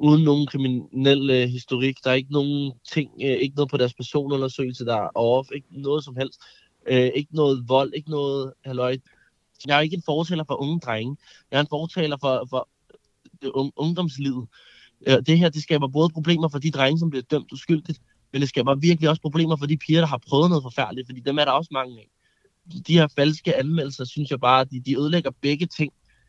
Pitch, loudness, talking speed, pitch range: 140 Hz, -23 LUFS, 205 wpm, 130-155 Hz